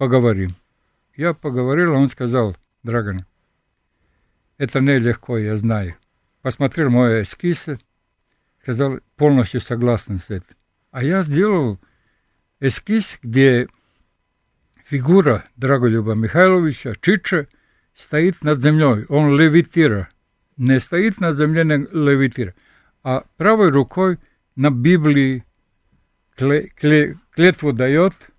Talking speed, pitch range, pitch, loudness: 100 wpm, 110-150 Hz, 135 Hz, -17 LUFS